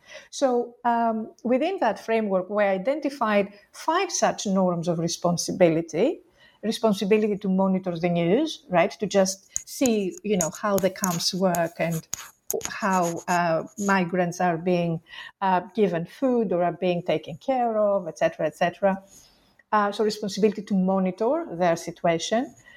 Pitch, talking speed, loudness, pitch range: 195 Hz, 140 wpm, -25 LUFS, 175-220 Hz